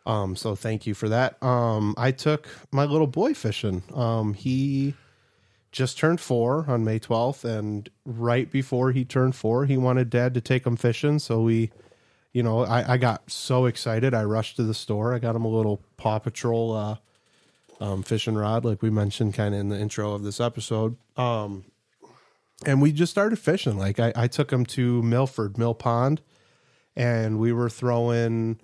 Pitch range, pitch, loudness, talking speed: 110-130 Hz, 120 Hz, -25 LUFS, 185 wpm